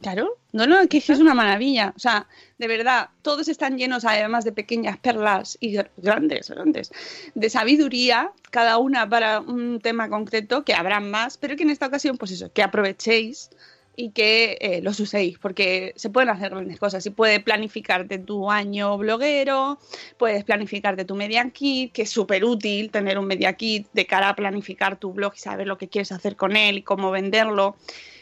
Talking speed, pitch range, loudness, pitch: 195 wpm, 200-250 Hz, -21 LUFS, 220 Hz